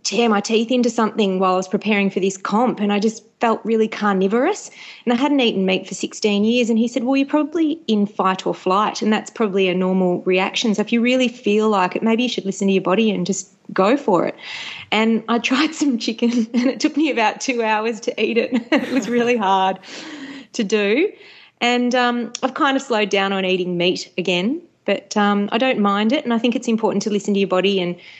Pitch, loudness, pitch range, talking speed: 220 Hz, -19 LUFS, 195-245 Hz, 235 wpm